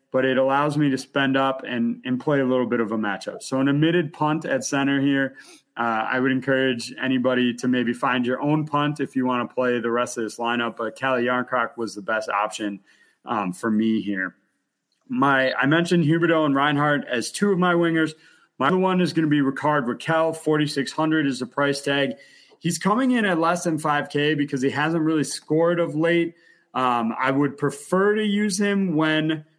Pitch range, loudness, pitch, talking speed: 125-155 Hz, -22 LUFS, 140 Hz, 215 wpm